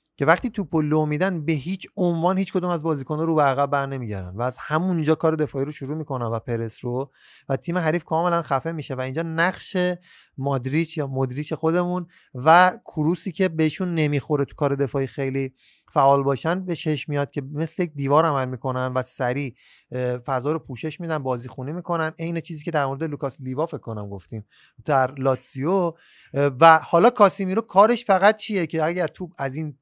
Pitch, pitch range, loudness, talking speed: 155 Hz, 135-170 Hz, -23 LUFS, 185 wpm